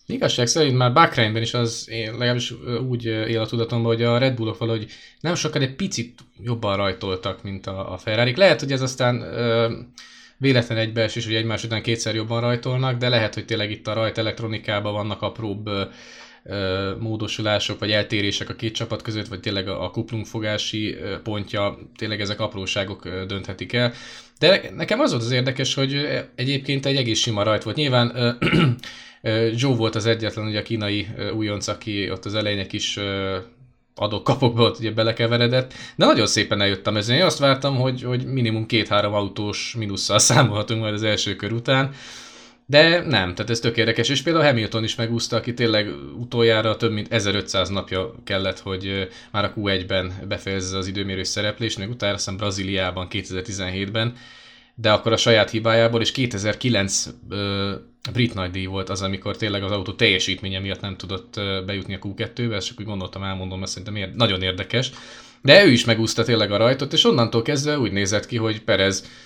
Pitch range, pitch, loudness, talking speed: 100-120 Hz, 110 Hz, -21 LUFS, 175 wpm